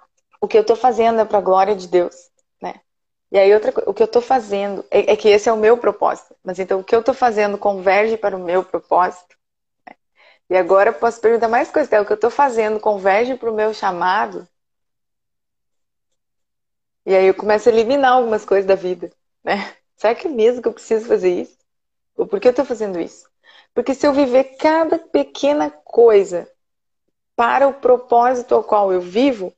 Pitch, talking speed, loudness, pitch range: 230 Hz, 205 wpm, -16 LUFS, 200-275 Hz